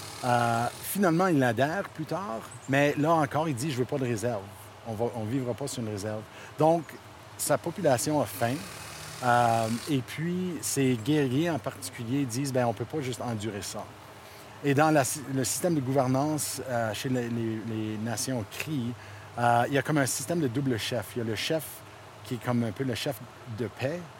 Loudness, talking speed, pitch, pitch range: -29 LUFS, 200 wpm, 125 Hz, 115-145 Hz